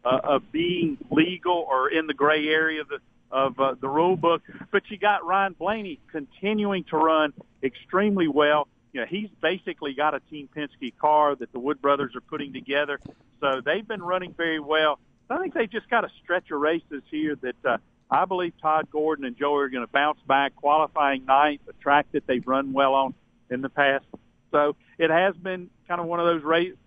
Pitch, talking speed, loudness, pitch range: 155 Hz, 210 wpm, -25 LUFS, 140-175 Hz